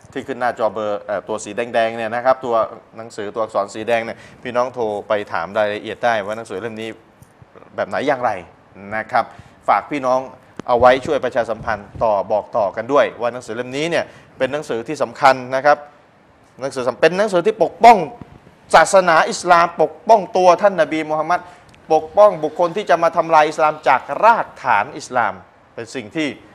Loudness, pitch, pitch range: -17 LUFS, 130 Hz, 115-160 Hz